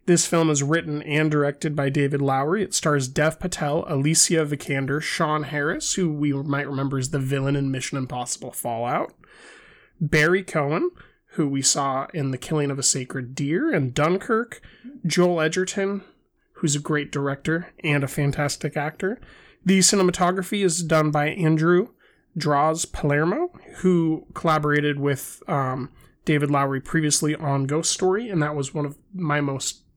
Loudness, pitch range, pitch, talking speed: -23 LUFS, 140-175 Hz, 150 Hz, 155 wpm